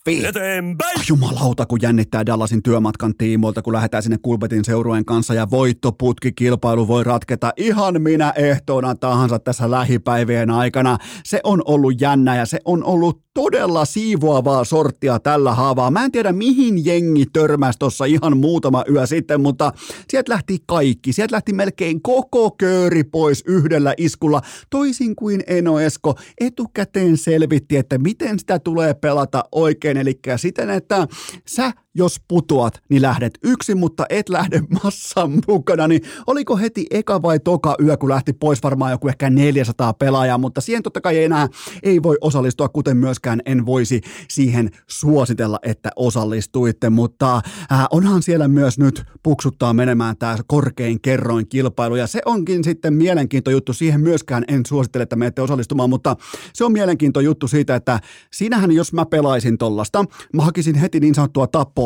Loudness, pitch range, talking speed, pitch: -17 LUFS, 125-170 Hz, 155 wpm, 145 Hz